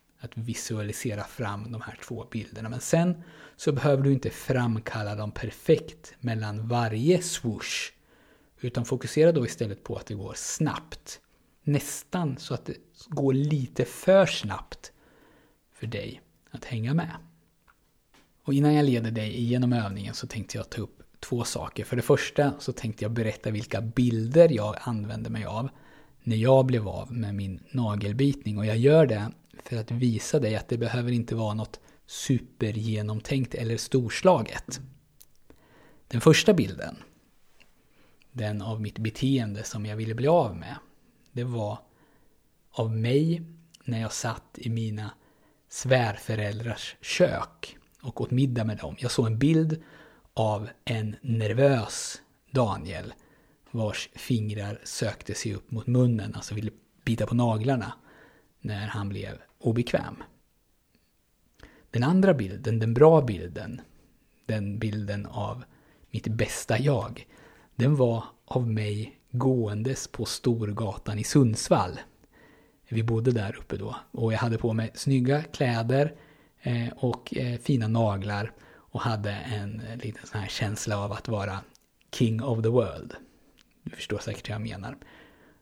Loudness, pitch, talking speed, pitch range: -27 LUFS, 115 Hz, 140 wpm, 110-135 Hz